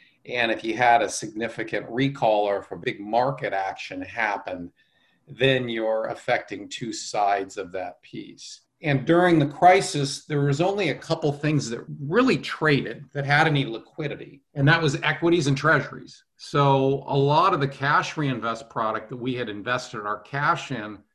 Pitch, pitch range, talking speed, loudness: 140 Hz, 120-155 Hz, 170 wpm, -24 LUFS